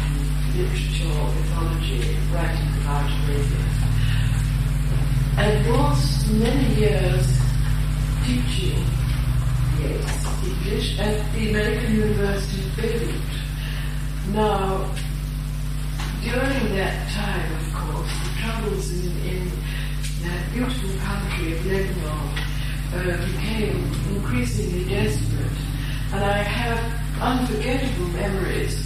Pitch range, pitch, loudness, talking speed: 135-150 Hz, 145 Hz, -24 LUFS, 85 wpm